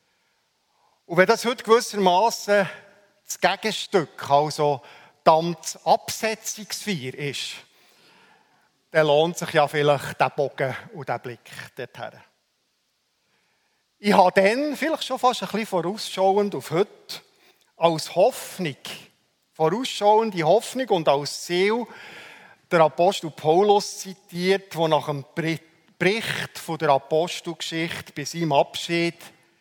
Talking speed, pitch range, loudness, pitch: 110 wpm, 155-205 Hz, -23 LUFS, 175 Hz